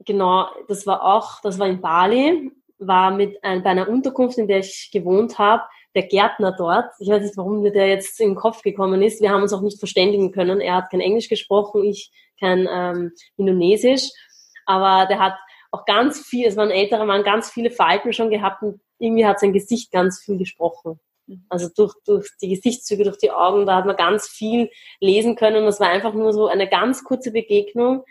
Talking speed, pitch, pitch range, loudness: 210 wpm, 205 Hz, 190-220 Hz, -19 LUFS